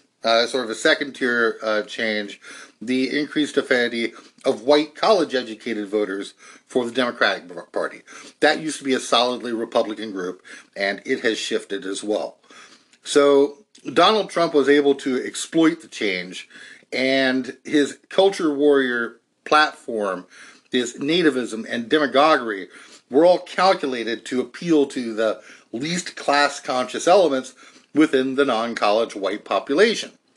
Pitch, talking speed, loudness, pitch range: 130 Hz, 130 wpm, -21 LUFS, 115-145 Hz